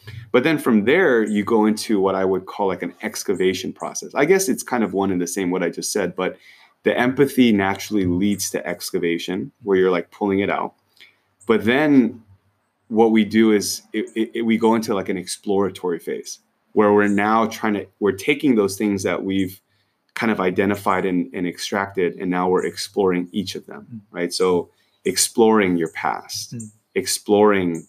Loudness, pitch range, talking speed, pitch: -20 LUFS, 95-110 Hz, 185 wpm, 100 Hz